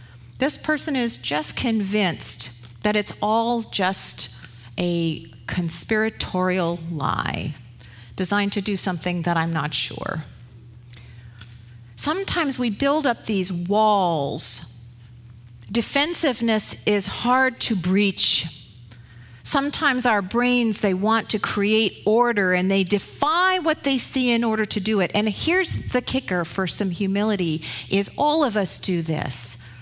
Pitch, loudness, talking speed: 190 Hz, -22 LUFS, 125 wpm